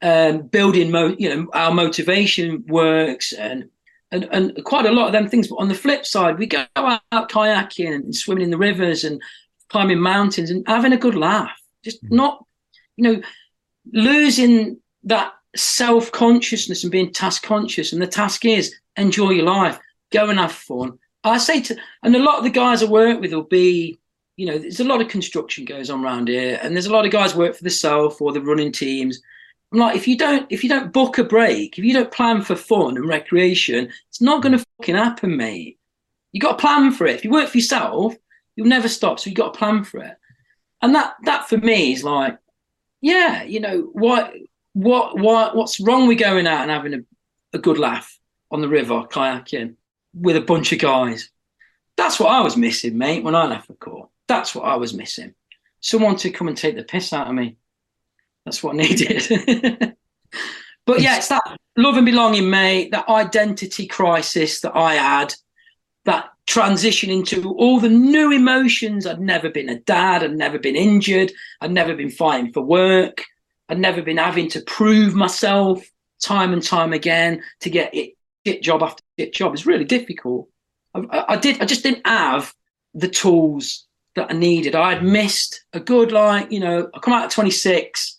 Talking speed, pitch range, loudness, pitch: 200 wpm, 165-230 Hz, -17 LUFS, 200 Hz